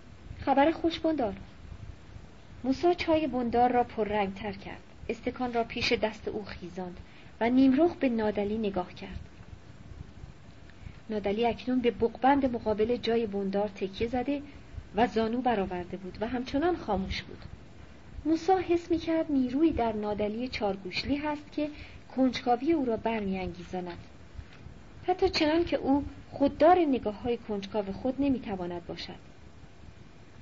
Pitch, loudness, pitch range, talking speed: 230 Hz, -29 LUFS, 195-275 Hz, 130 wpm